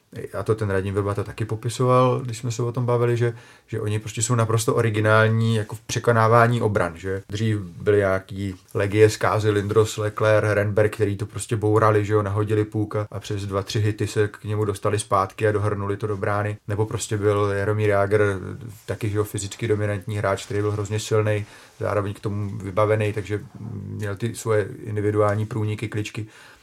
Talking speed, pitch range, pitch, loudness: 185 wpm, 105-110 Hz, 105 Hz, -23 LUFS